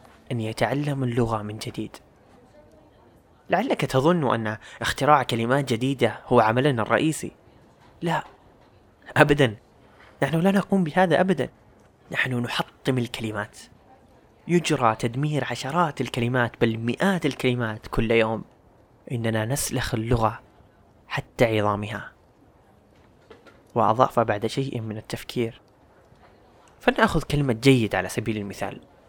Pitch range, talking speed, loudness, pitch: 110-140 Hz, 100 wpm, -24 LUFS, 120 Hz